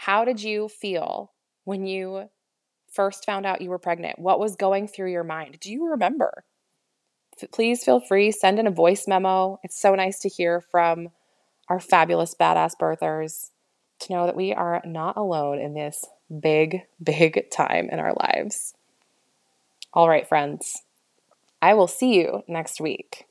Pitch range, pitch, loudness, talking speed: 160-195 Hz, 185 Hz, -23 LUFS, 165 wpm